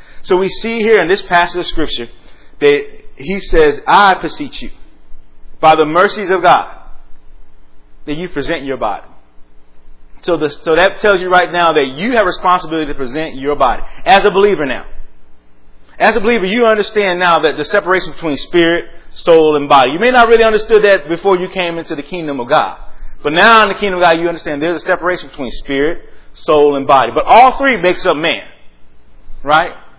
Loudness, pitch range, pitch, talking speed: -12 LUFS, 140-200 Hz, 170 Hz, 195 wpm